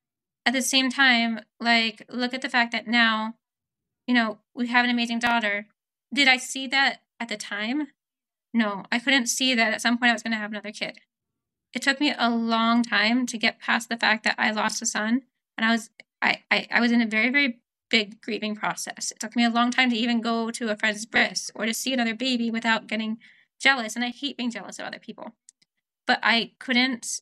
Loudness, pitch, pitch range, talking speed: -23 LUFS, 235 Hz, 220-245 Hz, 225 wpm